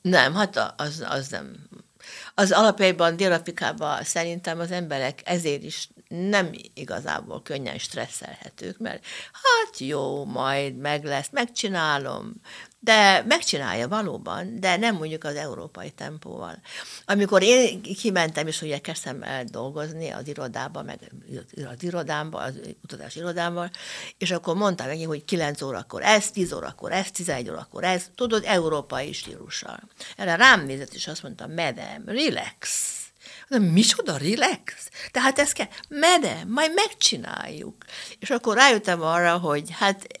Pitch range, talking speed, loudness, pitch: 155-215 Hz, 135 wpm, -23 LUFS, 180 Hz